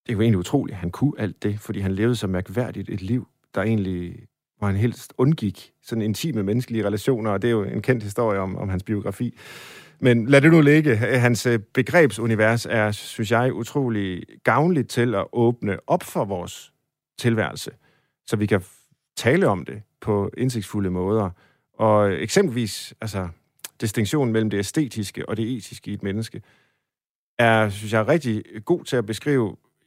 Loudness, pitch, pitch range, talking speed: -22 LUFS, 110 Hz, 100-125 Hz, 175 wpm